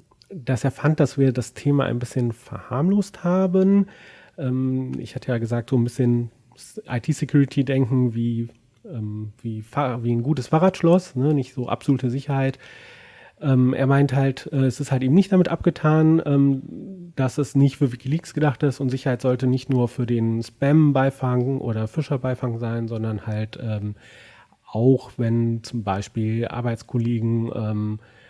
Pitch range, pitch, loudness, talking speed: 120-145 Hz, 130 Hz, -22 LUFS, 155 wpm